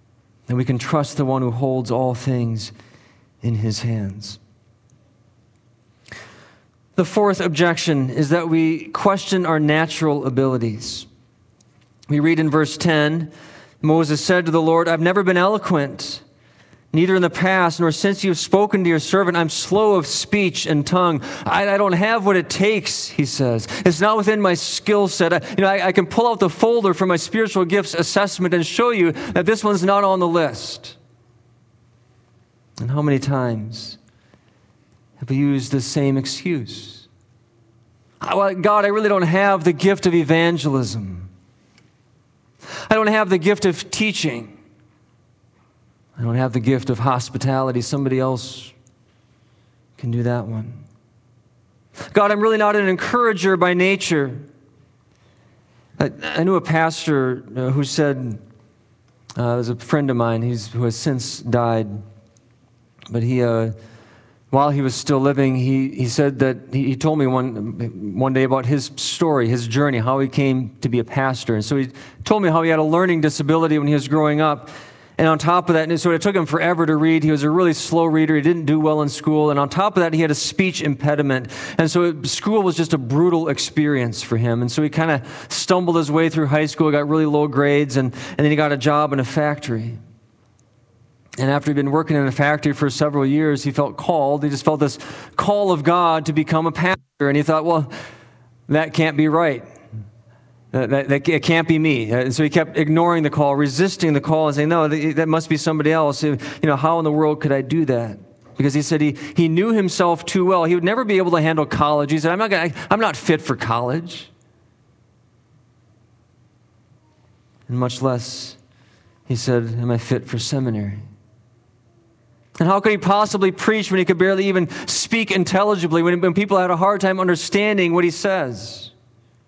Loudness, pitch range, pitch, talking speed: -18 LUFS, 120-170 Hz, 145 Hz, 190 wpm